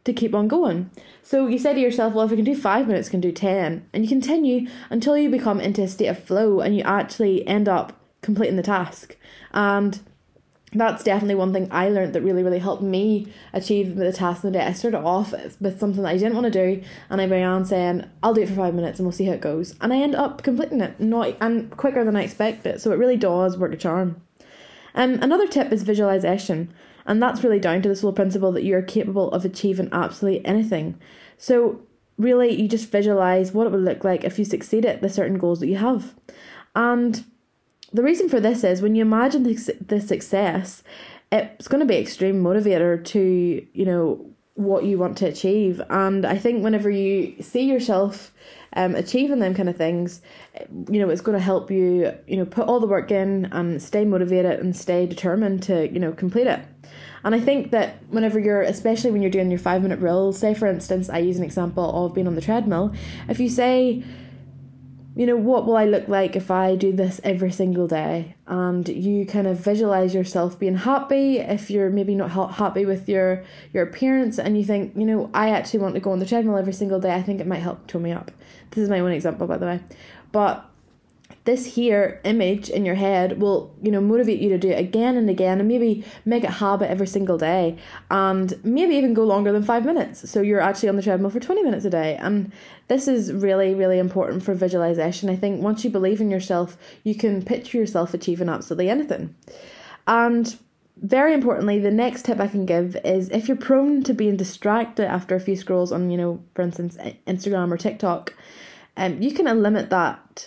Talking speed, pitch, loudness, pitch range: 215 wpm, 195 Hz, -21 LUFS, 185-225 Hz